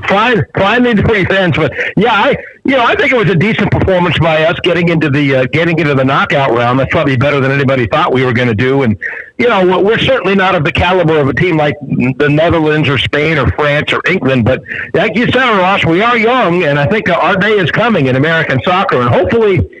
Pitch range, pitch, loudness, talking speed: 135-180 Hz, 155 Hz, -10 LUFS, 235 wpm